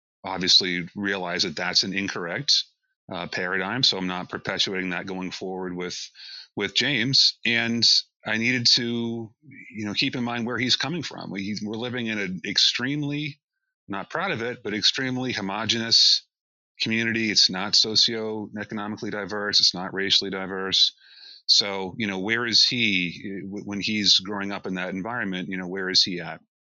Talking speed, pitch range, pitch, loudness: 160 wpm, 95-115 Hz, 105 Hz, -22 LUFS